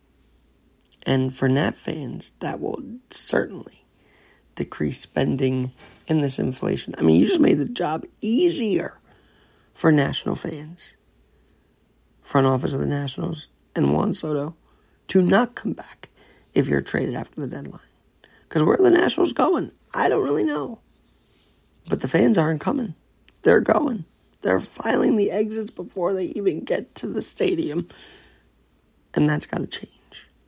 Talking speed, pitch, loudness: 145 wpm, 145 Hz, -23 LUFS